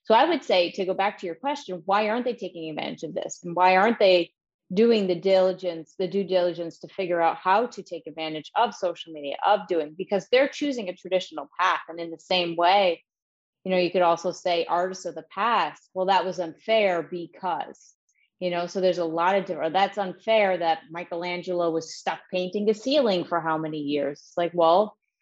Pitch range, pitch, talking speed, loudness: 170-195 Hz, 180 Hz, 210 wpm, -25 LUFS